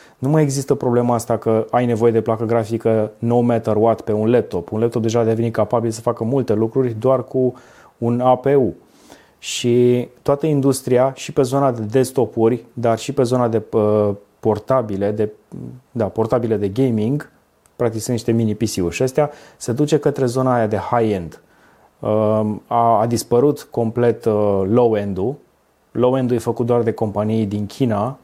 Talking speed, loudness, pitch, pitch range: 165 wpm, -18 LUFS, 115 Hz, 110-125 Hz